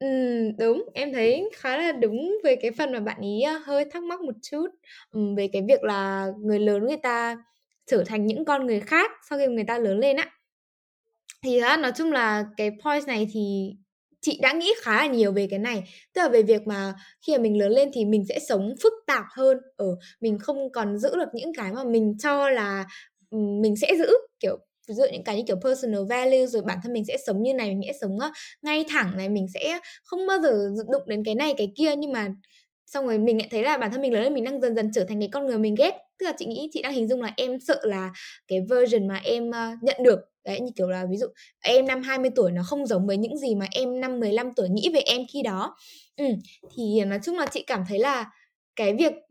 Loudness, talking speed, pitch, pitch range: -25 LUFS, 245 wpm, 240 Hz, 210-280 Hz